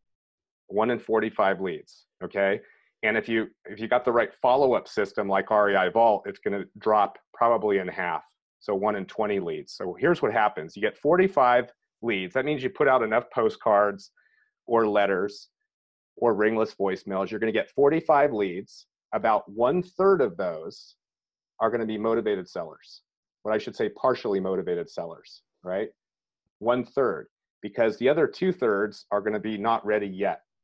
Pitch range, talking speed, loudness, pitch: 100-145 Hz, 175 wpm, -25 LUFS, 110 Hz